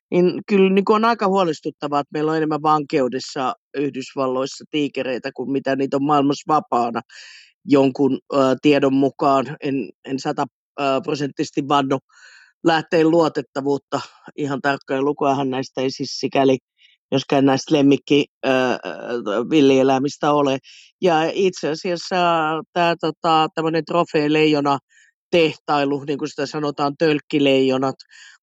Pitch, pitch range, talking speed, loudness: 145 Hz, 135-155 Hz, 110 wpm, -20 LUFS